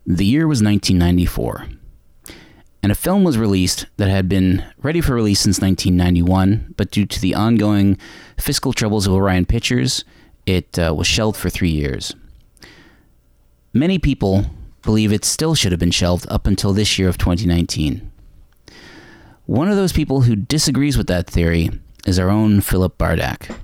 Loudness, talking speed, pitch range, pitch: -17 LUFS, 160 wpm, 90-110 Hz, 100 Hz